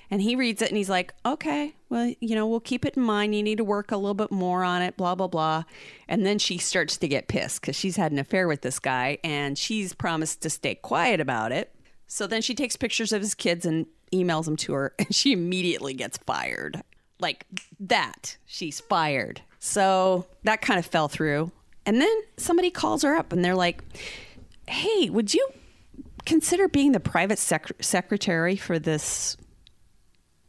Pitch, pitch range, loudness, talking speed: 185 Hz, 160-225 Hz, -25 LUFS, 195 wpm